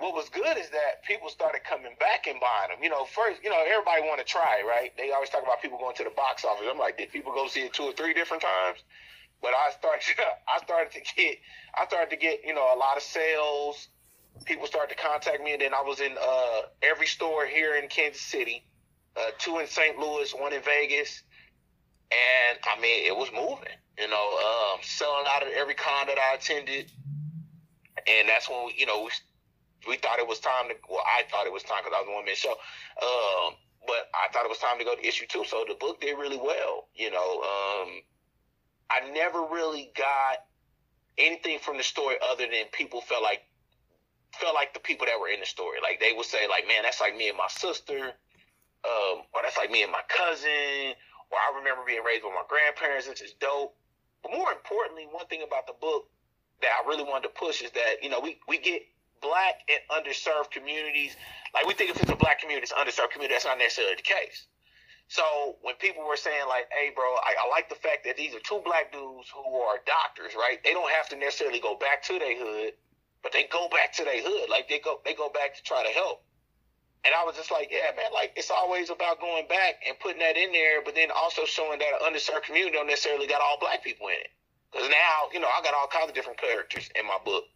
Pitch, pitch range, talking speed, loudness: 150 Hz, 140-190 Hz, 235 wpm, -27 LUFS